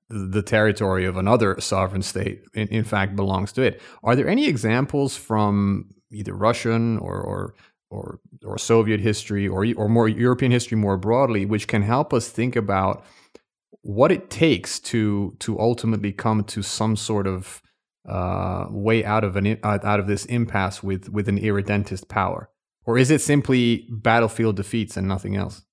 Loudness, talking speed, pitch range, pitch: -22 LUFS, 170 wpm, 100-115 Hz, 105 Hz